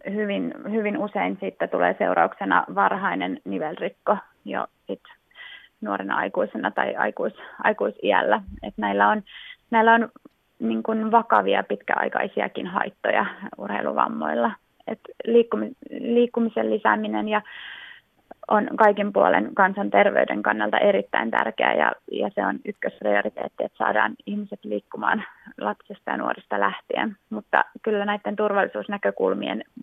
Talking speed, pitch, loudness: 105 wpm, 210 Hz, -23 LUFS